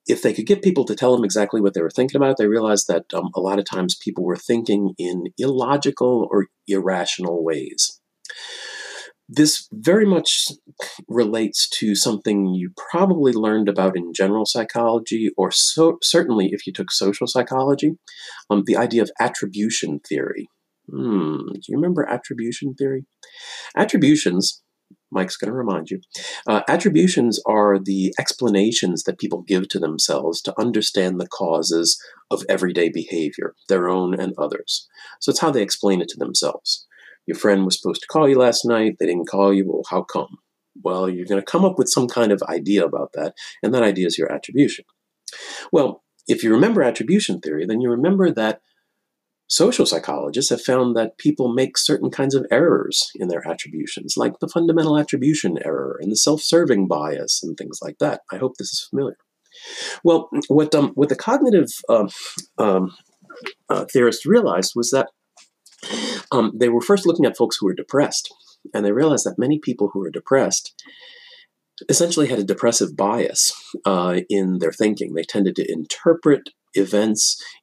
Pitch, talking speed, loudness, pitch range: 120 Hz, 170 wpm, -19 LUFS, 100-150 Hz